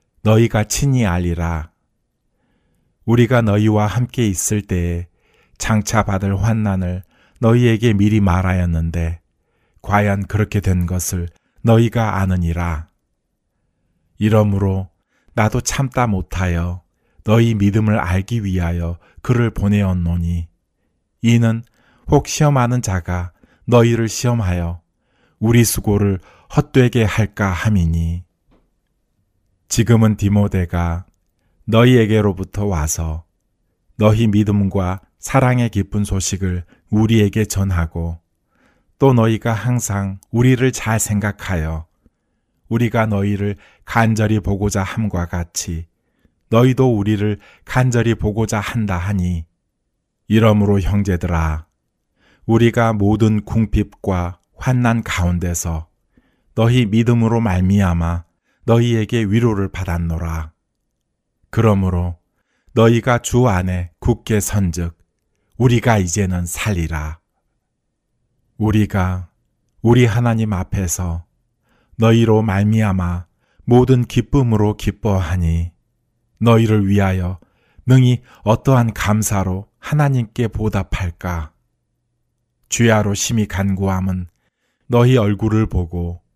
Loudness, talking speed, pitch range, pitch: -17 LUFS, 225 characters per minute, 90-115 Hz, 100 Hz